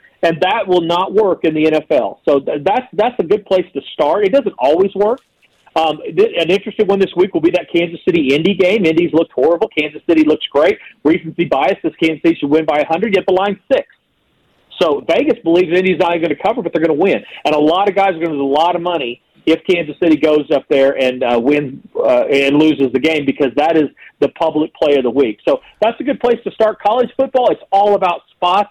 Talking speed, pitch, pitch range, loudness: 245 wpm, 170 Hz, 155-195 Hz, -14 LUFS